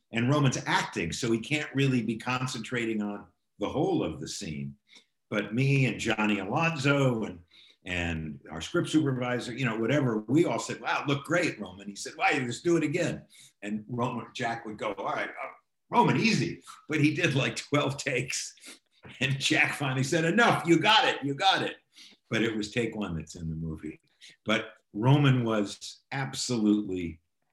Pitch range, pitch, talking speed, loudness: 105-145 Hz, 120 Hz, 180 wpm, -28 LUFS